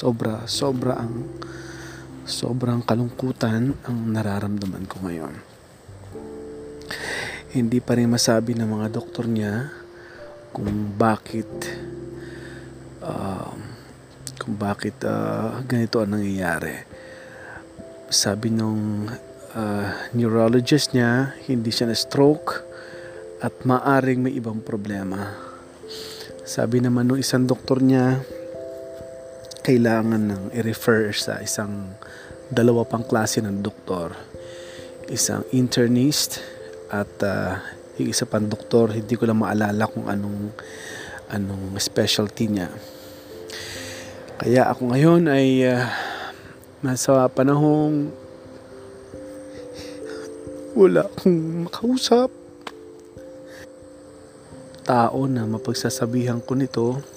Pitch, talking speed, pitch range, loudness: 115 Hz, 90 wpm, 100-130 Hz, -22 LUFS